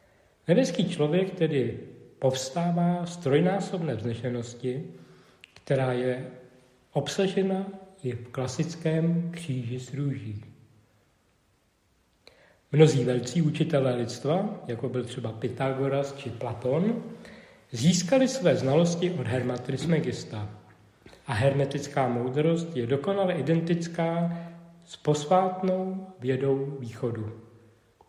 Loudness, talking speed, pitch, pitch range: -27 LUFS, 90 wpm, 140 Hz, 125-170 Hz